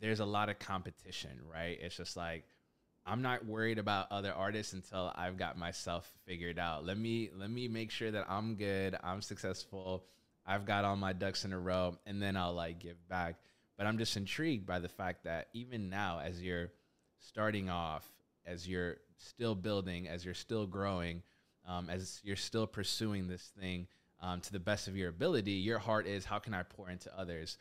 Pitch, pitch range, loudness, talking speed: 95 Hz, 90-105 Hz, -40 LUFS, 200 wpm